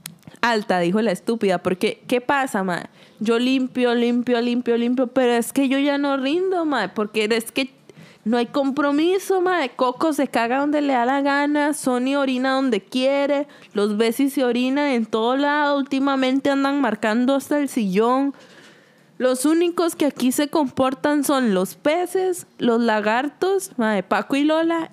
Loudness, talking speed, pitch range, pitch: -20 LUFS, 165 wpm, 230-285 Hz, 260 Hz